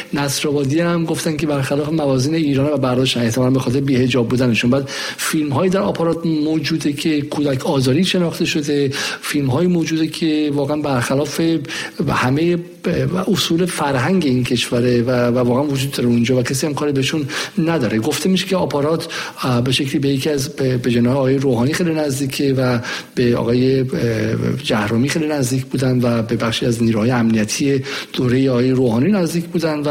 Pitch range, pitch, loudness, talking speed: 125-160 Hz, 140 Hz, -17 LUFS, 155 wpm